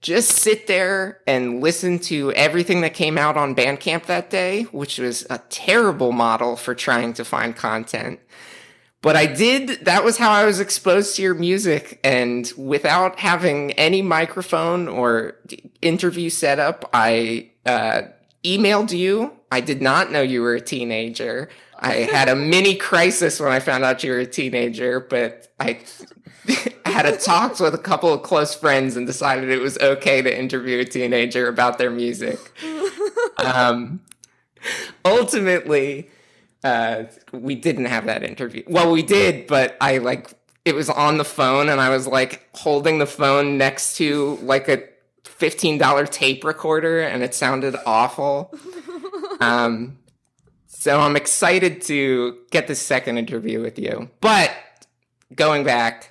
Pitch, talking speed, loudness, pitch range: 140 Hz, 155 wpm, -19 LUFS, 125-175 Hz